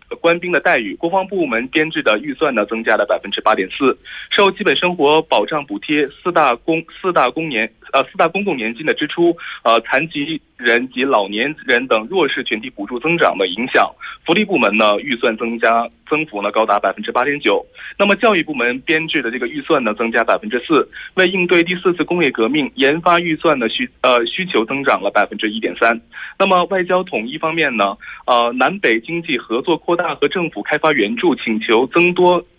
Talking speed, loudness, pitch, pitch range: 305 characters per minute, -16 LUFS, 155 Hz, 120-180 Hz